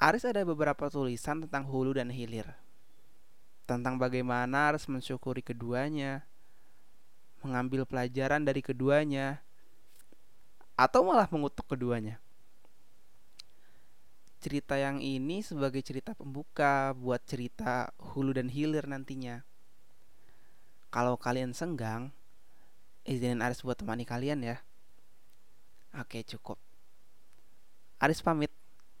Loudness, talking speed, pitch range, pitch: -33 LUFS, 95 wpm, 125-145 Hz, 135 Hz